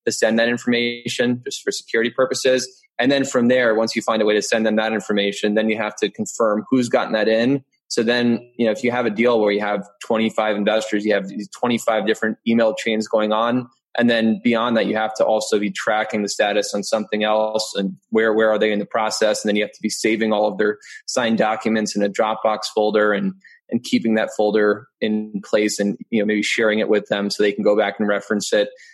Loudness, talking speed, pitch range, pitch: -20 LUFS, 240 wpm, 105-120 Hz, 110 Hz